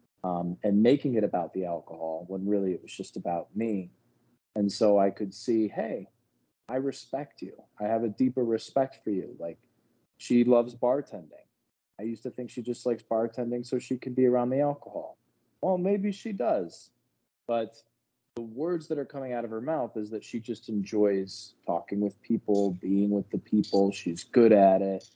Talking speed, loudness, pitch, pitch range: 190 wpm, -29 LUFS, 115 Hz, 100-125 Hz